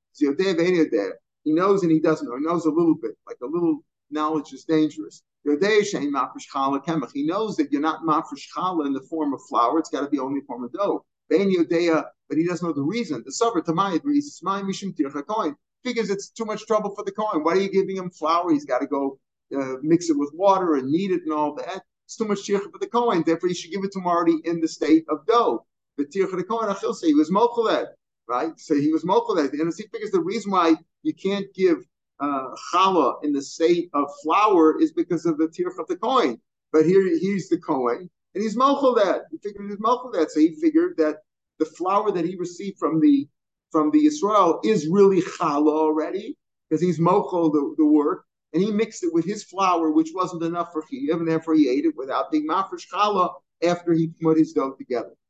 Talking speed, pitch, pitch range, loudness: 205 wpm, 175 Hz, 155-210 Hz, -23 LUFS